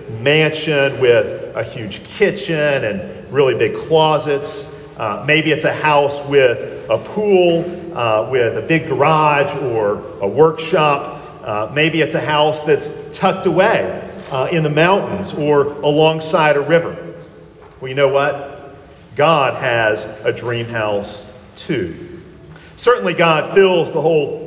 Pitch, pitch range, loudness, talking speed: 150 Hz, 140-185 Hz, -16 LUFS, 135 wpm